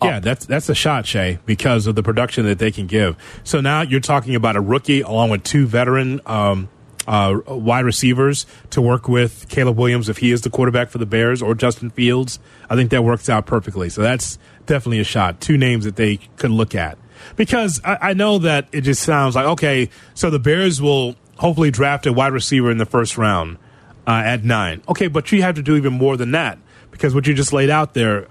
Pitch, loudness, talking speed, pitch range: 125 Hz, -17 LUFS, 225 wpm, 110-140 Hz